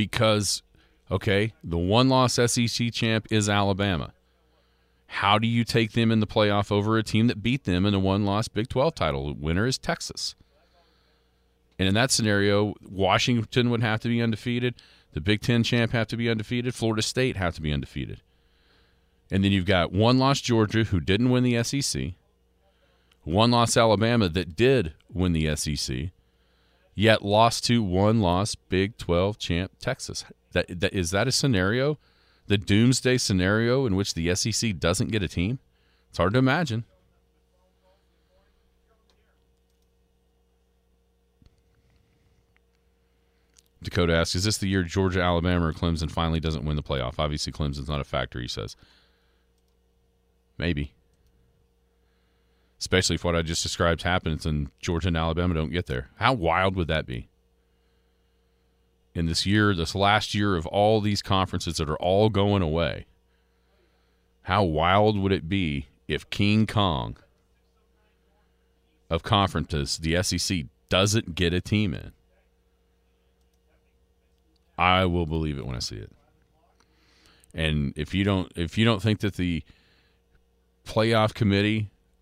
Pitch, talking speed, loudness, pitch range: 95 Hz, 145 wpm, -25 LUFS, 80-110 Hz